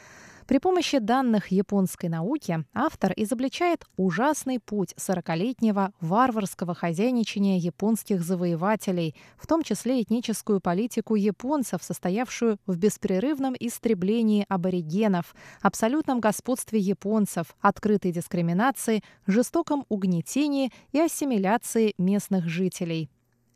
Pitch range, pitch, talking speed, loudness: 185-245 Hz, 210 Hz, 90 wpm, -26 LUFS